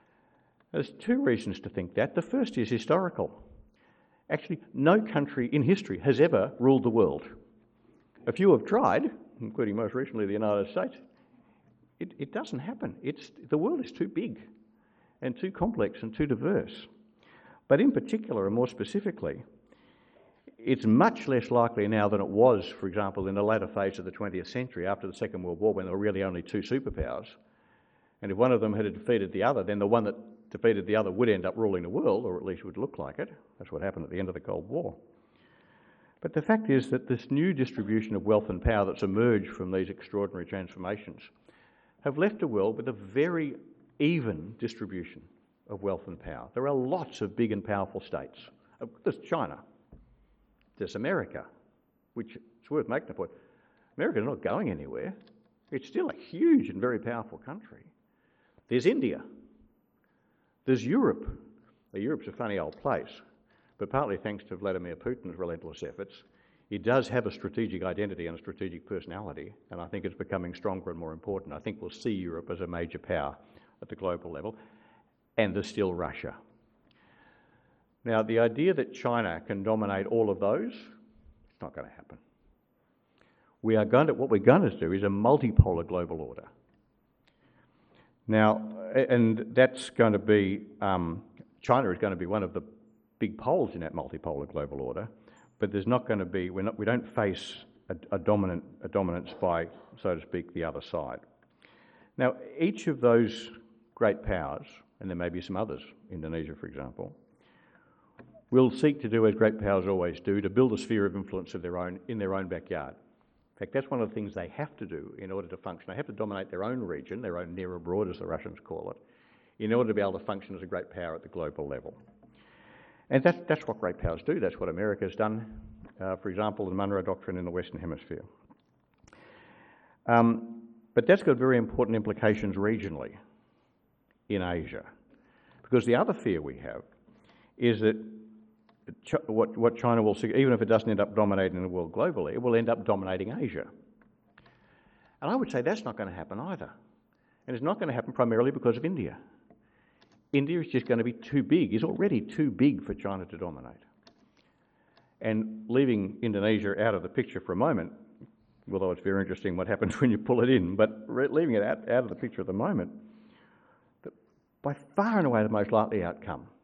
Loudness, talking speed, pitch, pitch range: -30 LUFS, 190 wpm, 110 Hz, 95-125 Hz